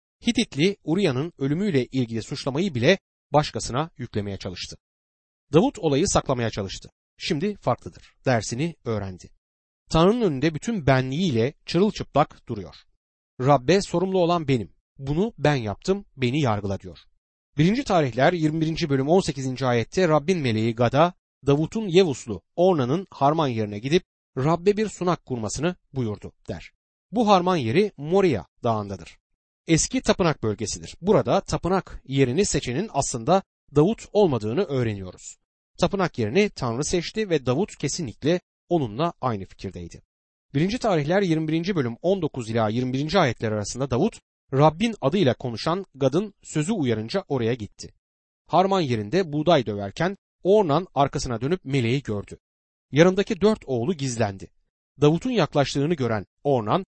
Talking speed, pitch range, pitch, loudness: 120 wpm, 115-180 Hz, 145 Hz, -24 LUFS